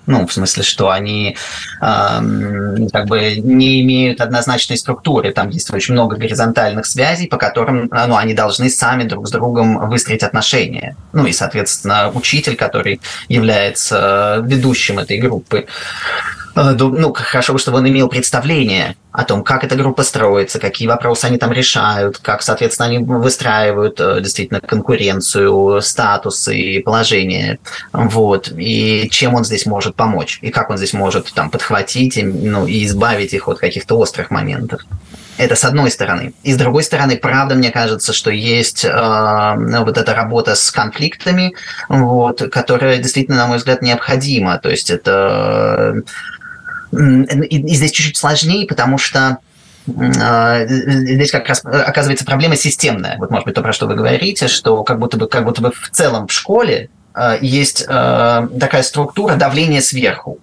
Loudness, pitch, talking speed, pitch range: -13 LUFS, 120 Hz, 155 wpm, 110-135 Hz